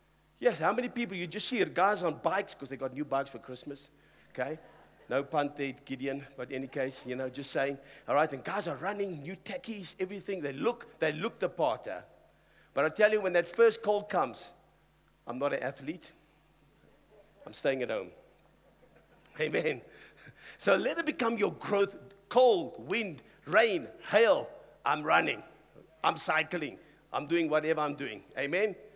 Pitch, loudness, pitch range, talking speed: 175 Hz, -32 LUFS, 140-210 Hz, 175 wpm